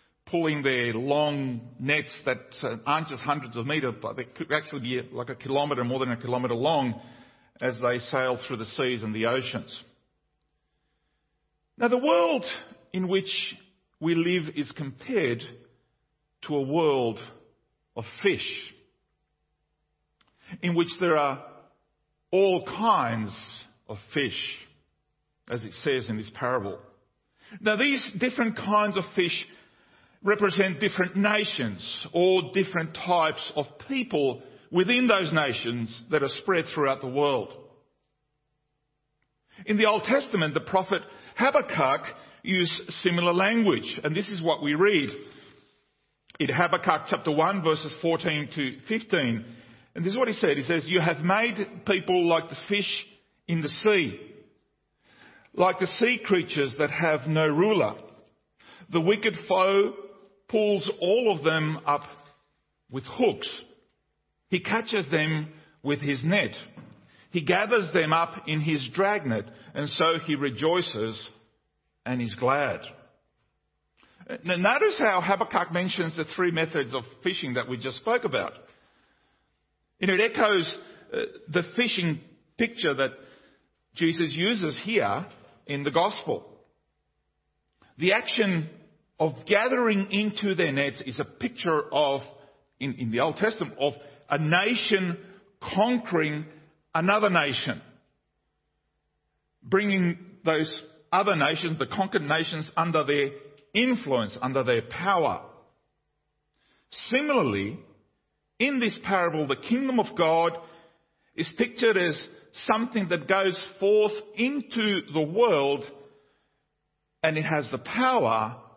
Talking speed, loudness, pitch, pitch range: 125 wpm, -26 LUFS, 165 Hz, 140-195 Hz